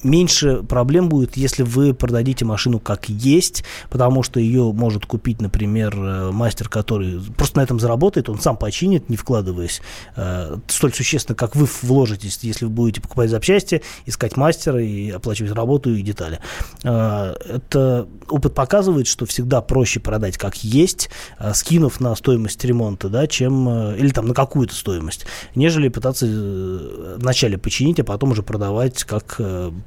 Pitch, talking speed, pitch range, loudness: 120 Hz, 155 wpm, 105-130 Hz, -19 LUFS